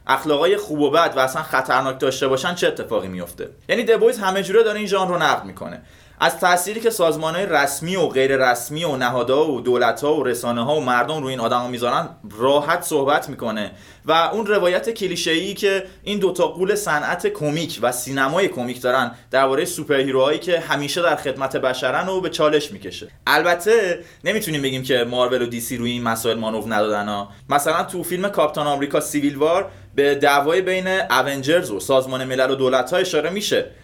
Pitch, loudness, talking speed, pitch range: 150 Hz, -20 LUFS, 185 wpm, 130-185 Hz